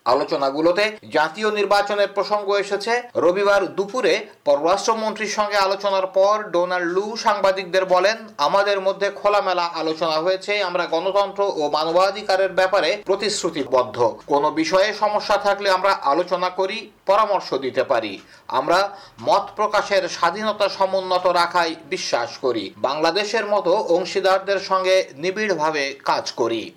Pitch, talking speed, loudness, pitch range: 195 Hz, 115 wpm, -20 LUFS, 180-205 Hz